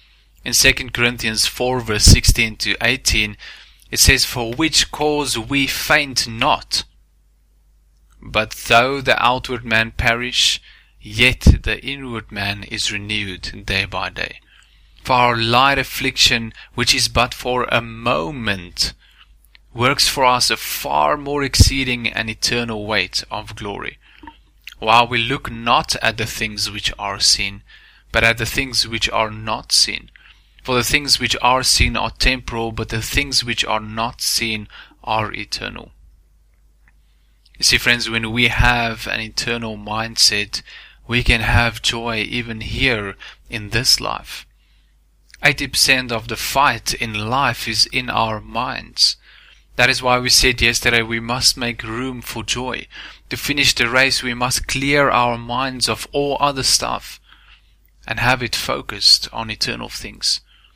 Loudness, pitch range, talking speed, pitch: -17 LUFS, 110-125 Hz, 145 wpm, 115 Hz